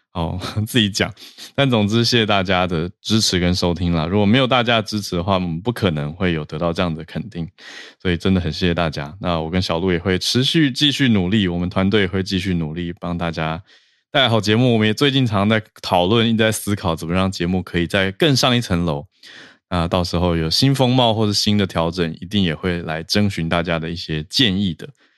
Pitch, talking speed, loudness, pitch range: 95 Hz, 330 characters per minute, -18 LUFS, 85-110 Hz